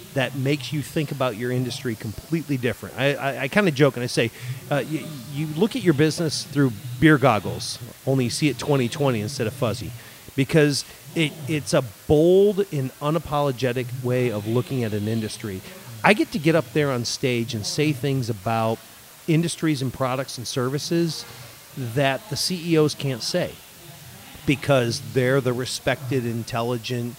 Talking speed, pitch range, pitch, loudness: 170 wpm, 120-150 Hz, 135 Hz, -23 LUFS